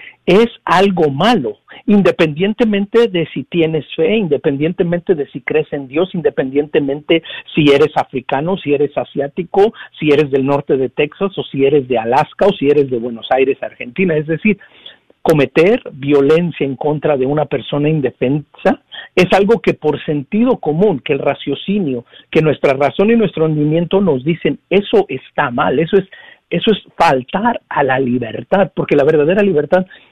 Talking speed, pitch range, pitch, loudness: 160 wpm, 145-195 Hz, 155 Hz, -15 LUFS